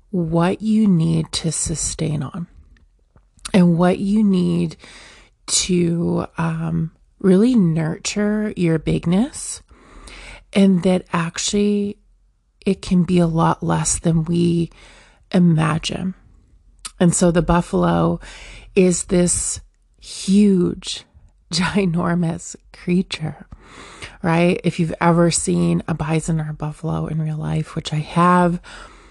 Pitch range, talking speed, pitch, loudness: 160-185 Hz, 110 wpm, 170 Hz, -19 LUFS